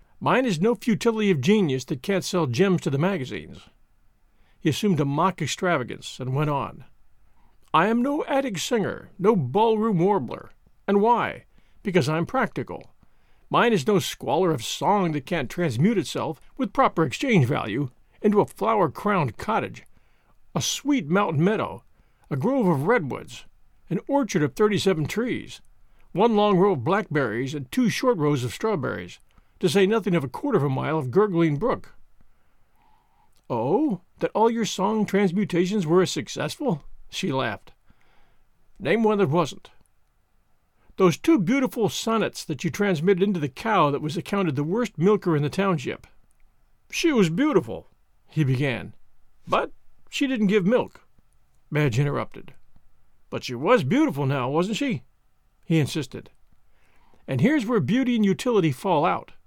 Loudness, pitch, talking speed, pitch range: -24 LUFS, 190 Hz, 155 wpm, 155-220 Hz